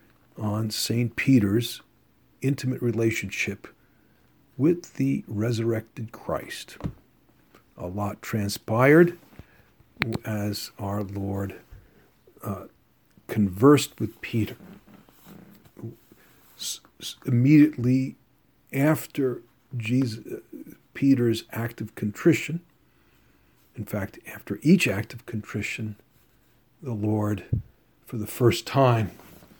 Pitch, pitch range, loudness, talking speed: 115 Hz, 105-130 Hz, -25 LUFS, 80 wpm